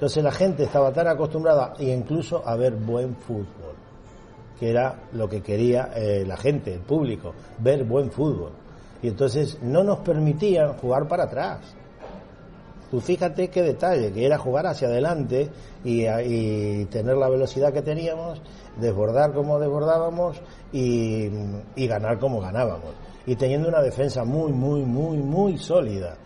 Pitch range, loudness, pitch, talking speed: 115-150 Hz, -24 LUFS, 130 Hz, 150 wpm